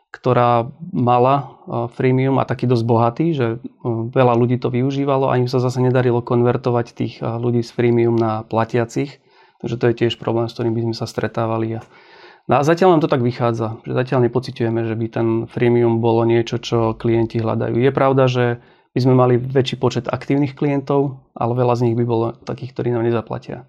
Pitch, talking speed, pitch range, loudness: 120 Hz, 185 wpm, 115-130 Hz, -18 LUFS